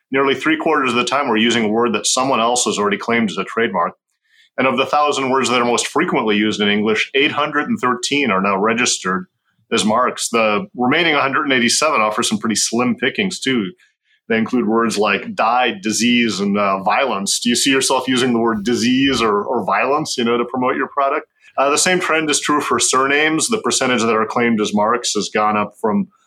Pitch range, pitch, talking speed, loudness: 110-135 Hz, 120 Hz, 220 wpm, -16 LUFS